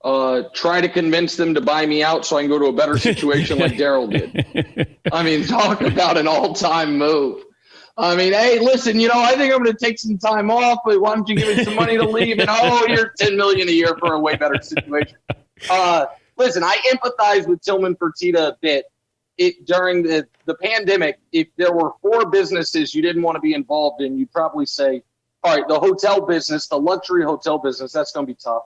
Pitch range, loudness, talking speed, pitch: 155-225 Hz, -17 LUFS, 225 wpm, 175 Hz